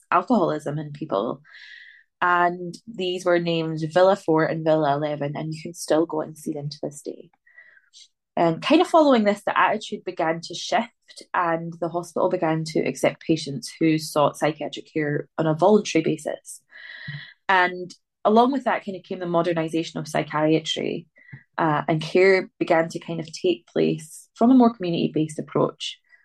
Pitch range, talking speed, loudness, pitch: 160-190 Hz, 170 wpm, -23 LUFS, 170 Hz